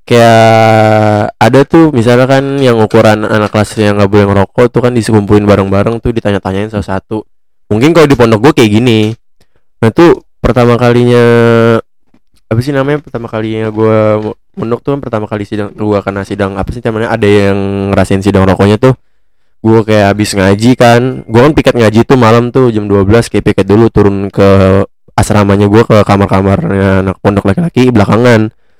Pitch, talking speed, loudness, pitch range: 110 Hz, 175 wpm, -8 LUFS, 100-120 Hz